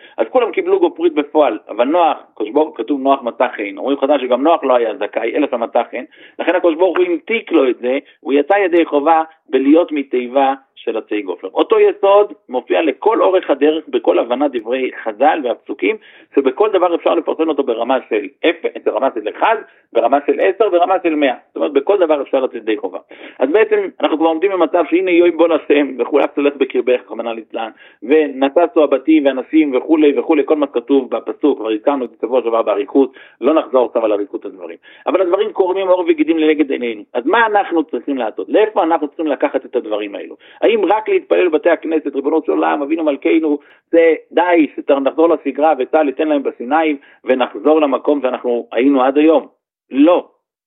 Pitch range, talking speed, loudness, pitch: 140-190 Hz, 175 wpm, -15 LUFS, 160 Hz